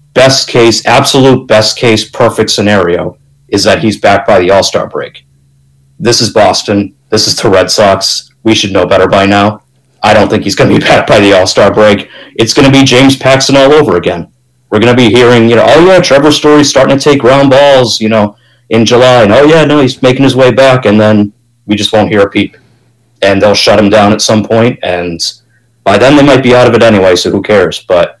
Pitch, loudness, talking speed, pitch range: 115 Hz, -6 LUFS, 230 wpm, 105-130 Hz